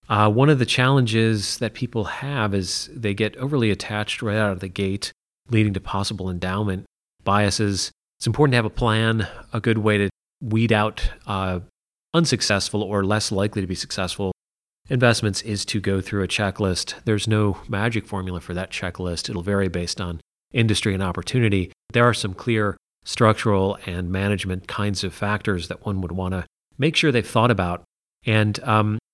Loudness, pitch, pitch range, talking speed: -22 LUFS, 105 Hz, 95-110 Hz, 175 wpm